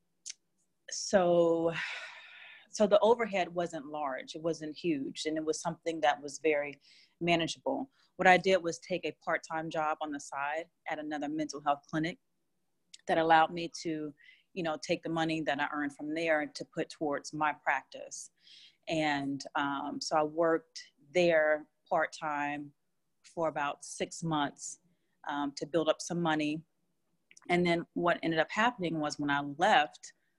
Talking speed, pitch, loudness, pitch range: 155 wpm, 160 Hz, -32 LUFS, 150-175 Hz